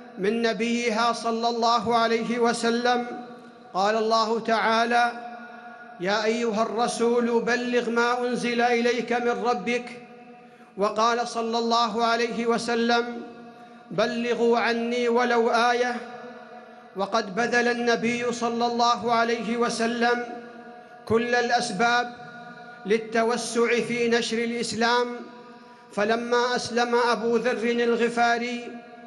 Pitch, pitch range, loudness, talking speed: 235 Hz, 230-240 Hz, -24 LUFS, 95 wpm